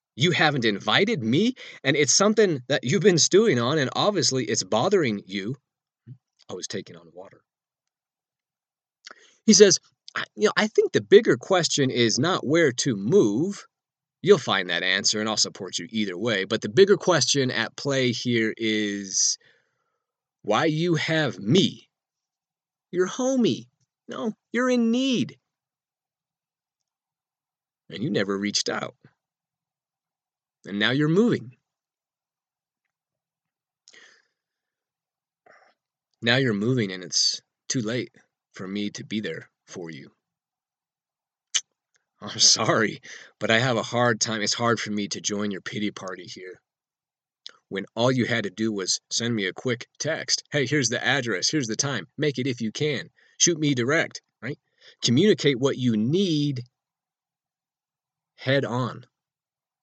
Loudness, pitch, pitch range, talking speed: -23 LUFS, 135 Hz, 110-160 Hz, 140 wpm